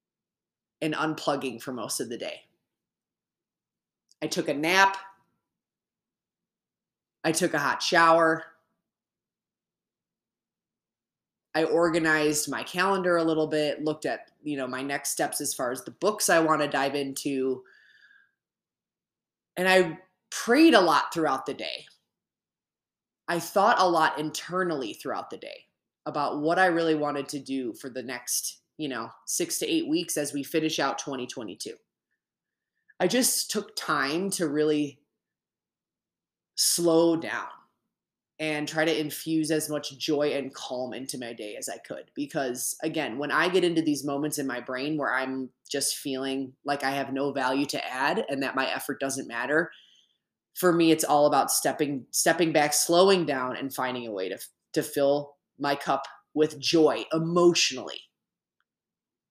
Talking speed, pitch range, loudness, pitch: 150 wpm, 140-170 Hz, -26 LUFS, 150 Hz